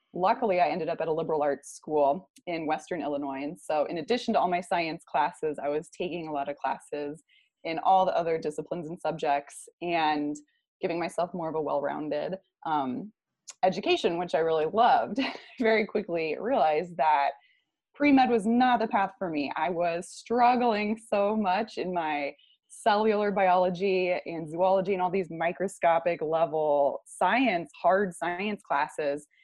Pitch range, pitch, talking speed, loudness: 155-205 Hz, 175 Hz, 165 wpm, -28 LUFS